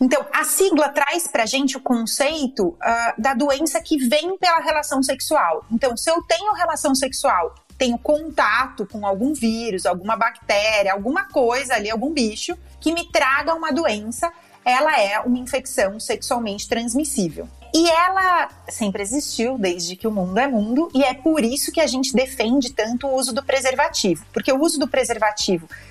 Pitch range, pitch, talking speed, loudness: 225-310 Hz, 270 Hz, 170 wpm, -20 LUFS